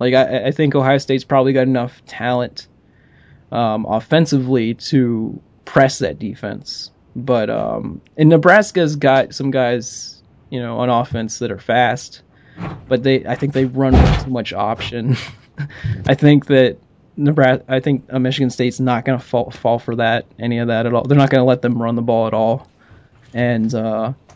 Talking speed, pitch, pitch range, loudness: 180 wpm, 125 Hz, 115-135 Hz, -16 LUFS